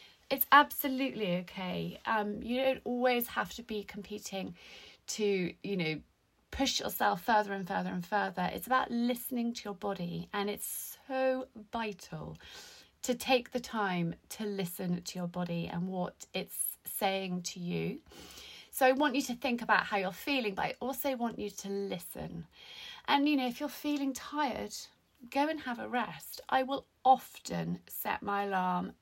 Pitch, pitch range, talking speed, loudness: 210 Hz, 190-260 Hz, 180 wpm, -33 LUFS